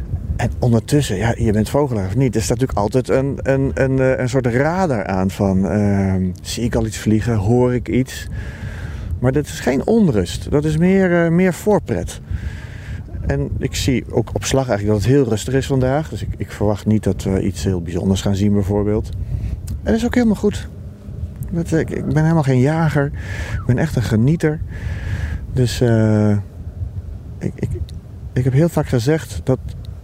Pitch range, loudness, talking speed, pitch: 95-130 Hz, -18 LUFS, 190 wpm, 110 Hz